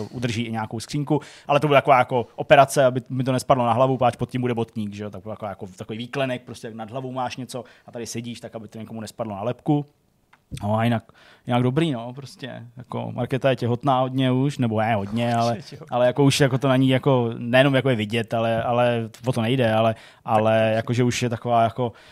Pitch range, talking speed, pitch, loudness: 115-130 Hz, 230 wpm, 120 Hz, -22 LUFS